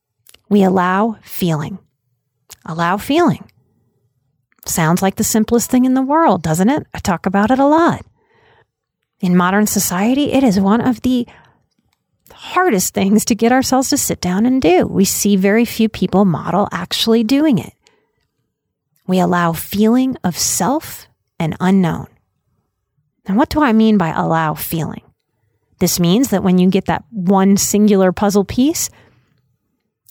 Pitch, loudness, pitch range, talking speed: 200 Hz, -15 LUFS, 175-245 Hz, 145 wpm